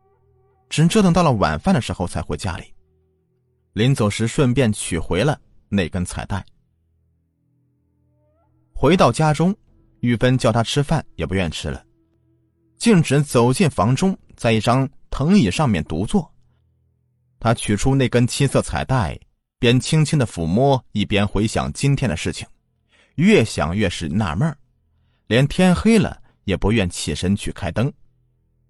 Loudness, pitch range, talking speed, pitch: -19 LUFS, 95-135 Hz, 205 characters per minute, 115 Hz